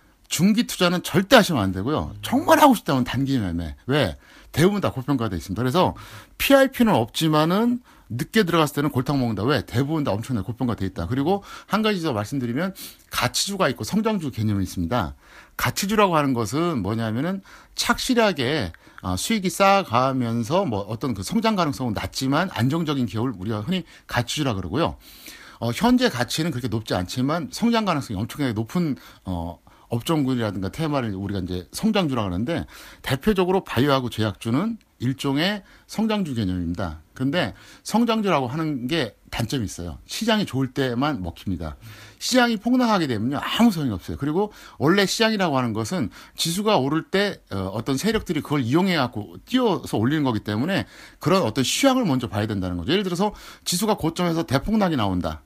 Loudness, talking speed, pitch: -23 LUFS, 395 characters per minute, 135 Hz